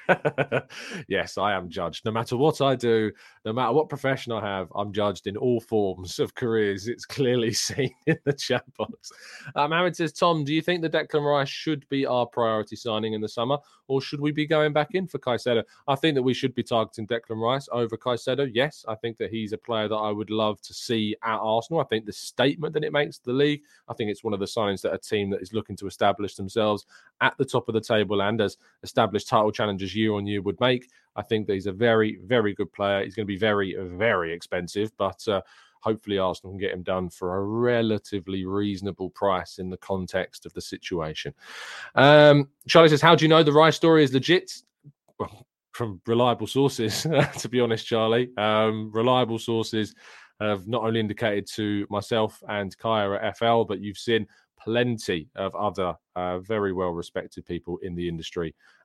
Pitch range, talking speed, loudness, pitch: 100-135 Hz, 210 wpm, -25 LUFS, 110 Hz